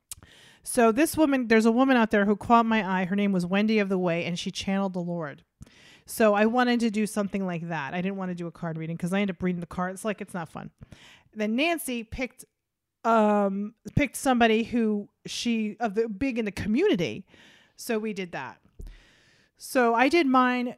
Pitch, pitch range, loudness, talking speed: 210 Hz, 190-235 Hz, -26 LUFS, 215 wpm